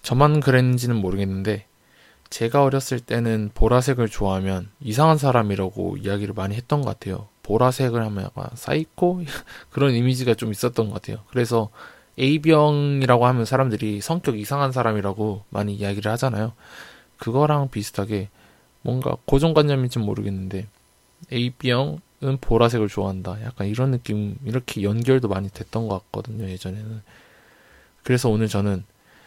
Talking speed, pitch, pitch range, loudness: 355 characters per minute, 115 Hz, 105-130 Hz, -22 LUFS